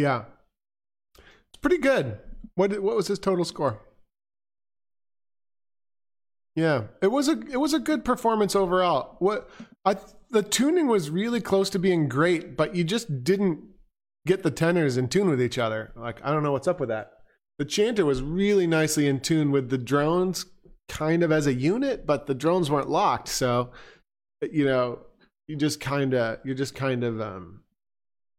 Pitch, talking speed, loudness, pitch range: 160 Hz, 175 wpm, -25 LUFS, 135-195 Hz